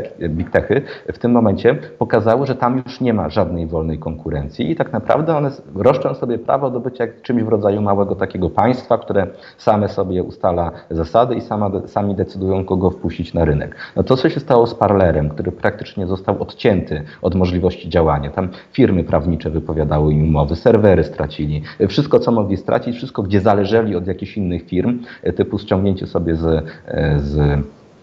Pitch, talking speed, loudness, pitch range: 95 Hz, 165 wpm, -18 LUFS, 80-110 Hz